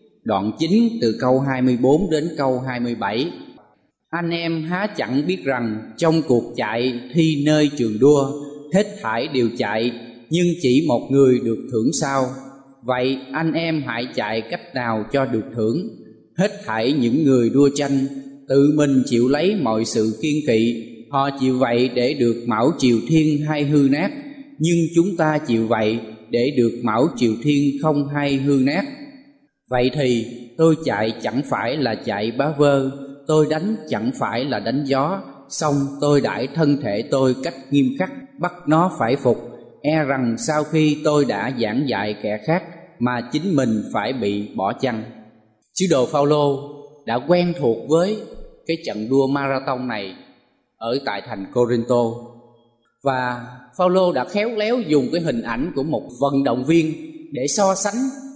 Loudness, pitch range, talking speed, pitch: -20 LUFS, 120-155 Hz, 165 wpm, 140 Hz